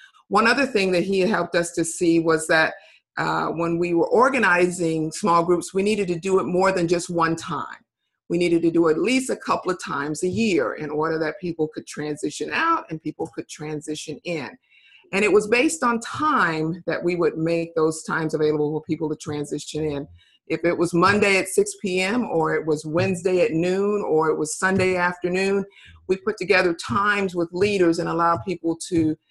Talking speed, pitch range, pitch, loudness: 205 wpm, 160-190 Hz, 170 Hz, -22 LUFS